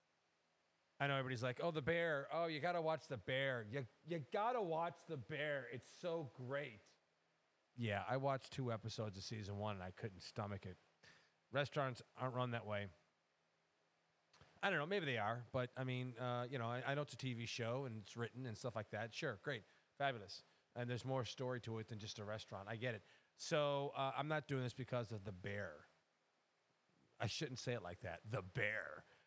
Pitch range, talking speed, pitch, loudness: 105-140 Hz, 210 wpm, 125 Hz, -45 LUFS